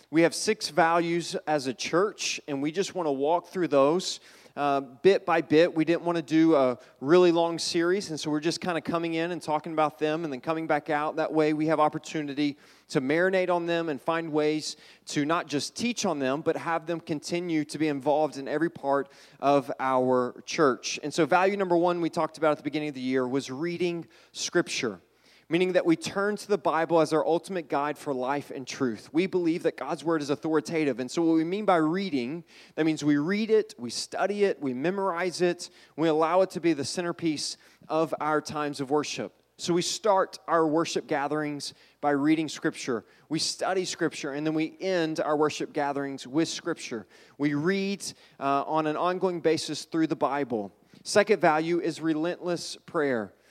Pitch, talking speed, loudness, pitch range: 160 Hz, 205 wpm, -27 LUFS, 145-175 Hz